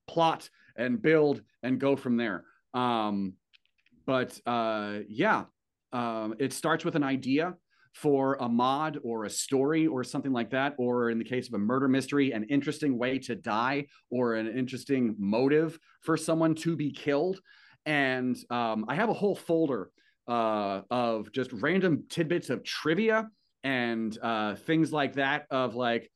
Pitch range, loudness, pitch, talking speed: 120-150 Hz, -29 LUFS, 130 Hz, 160 wpm